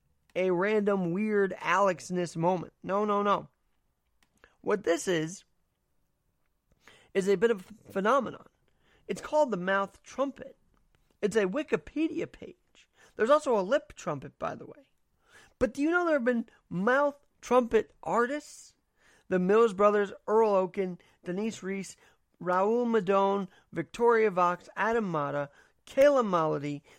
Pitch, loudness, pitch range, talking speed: 200 Hz, -29 LUFS, 180-235 Hz, 130 wpm